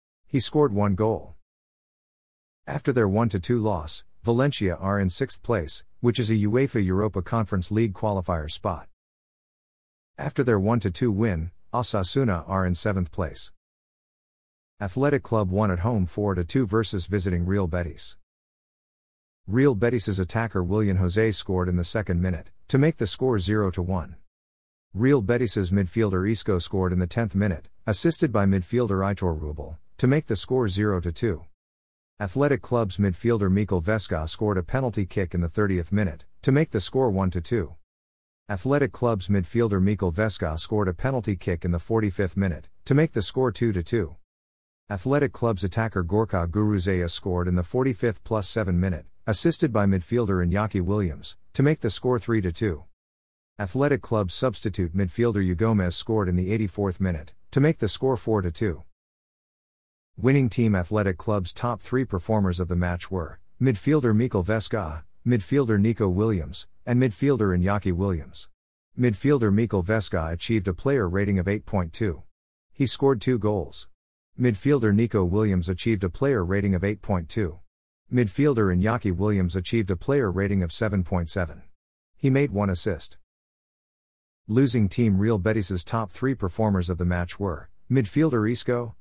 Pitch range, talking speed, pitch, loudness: 90-115 Hz, 150 wpm, 100 Hz, -25 LUFS